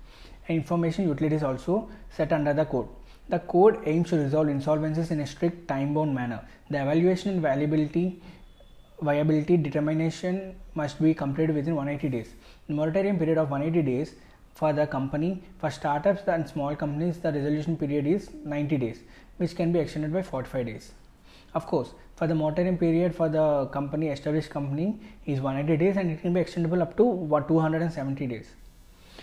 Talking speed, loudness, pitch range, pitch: 170 wpm, -27 LUFS, 145-170 Hz, 155 Hz